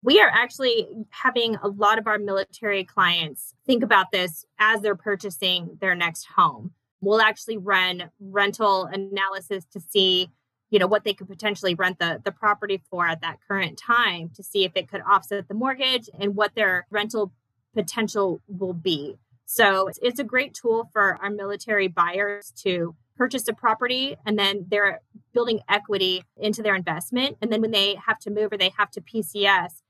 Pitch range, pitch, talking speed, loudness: 185-215 Hz, 200 Hz, 180 wpm, -23 LUFS